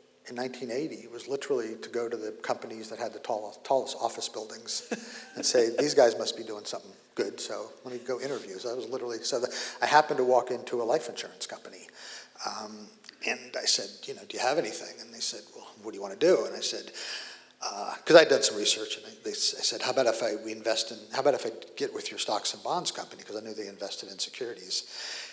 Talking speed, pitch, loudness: 240 wpm, 130 Hz, -29 LUFS